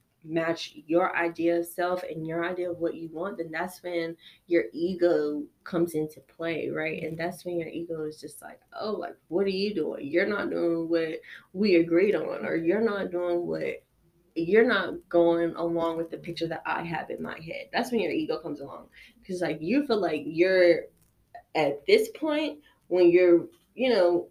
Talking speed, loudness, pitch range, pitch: 195 wpm, -27 LUFS, 165-195 Hz, 170 Hz